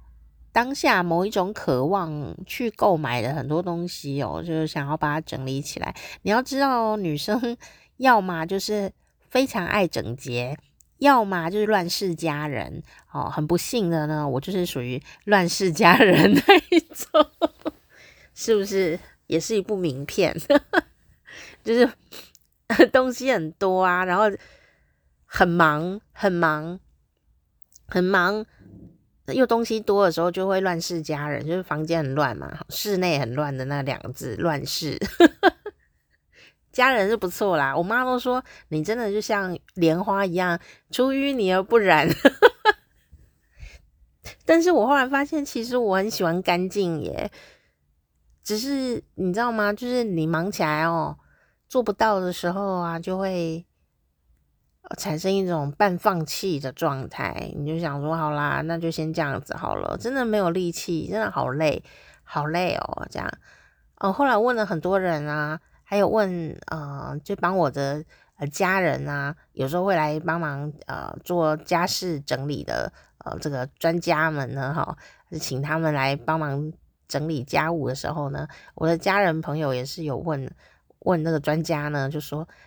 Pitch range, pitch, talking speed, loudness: 150-205 Hz, 170 Hz, 220 characters per minute, -23 LUFS